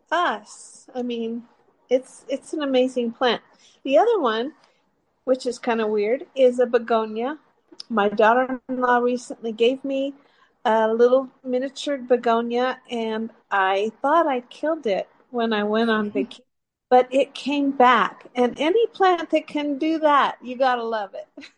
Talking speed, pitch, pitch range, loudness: 155 wpm, 250 Hz, 230-275 Hz, -22 LUFS